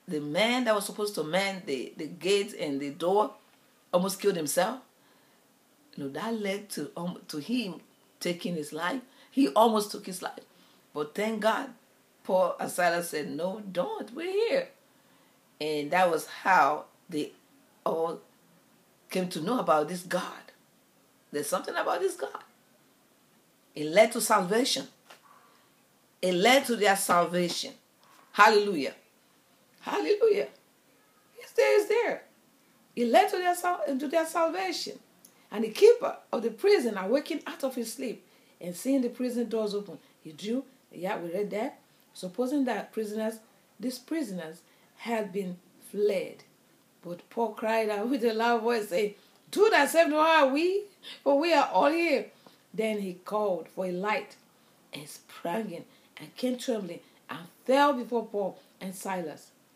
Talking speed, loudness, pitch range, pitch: 150 wpm, -28 LUFS, 185-275 Hz, 220 Hz